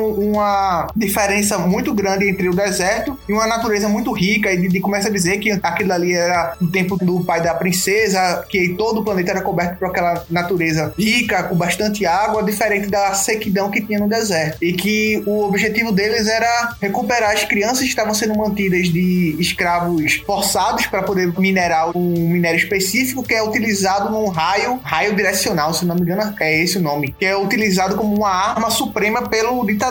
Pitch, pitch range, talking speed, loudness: 200 Hz, 180-215 Hz, 185 wpm, -17 LUFS